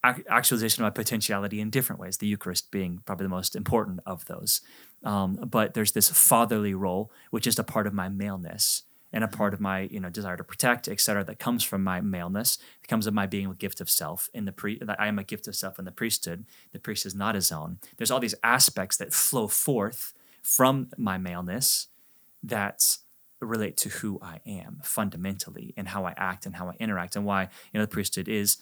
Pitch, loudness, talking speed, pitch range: 100 Hz, -26 LUFS, 220 wpm, 95-105 Hz